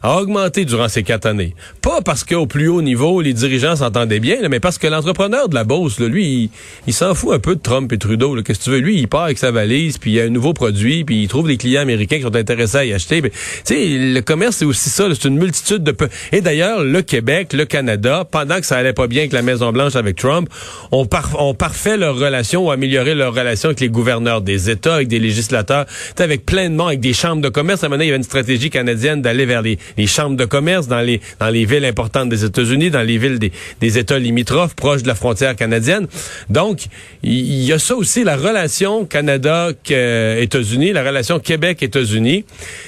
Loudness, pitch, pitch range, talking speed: -15 LUFS, 135 Hz, 120-155 Hz, 240 wpm